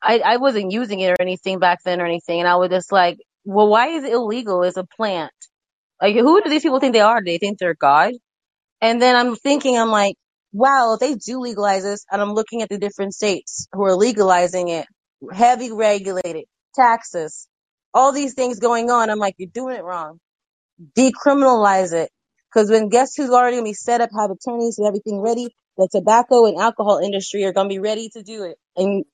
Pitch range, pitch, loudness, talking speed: 190-240 Hz, 210 Hz, -18 LUFS, 215 wpm